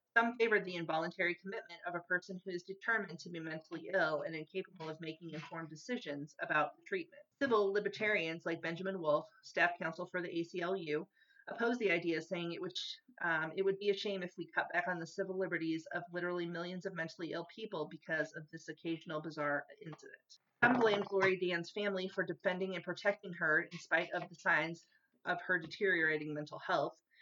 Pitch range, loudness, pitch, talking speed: 165-195 Hz, -37 LUFS, 175 Hz, 190 wpm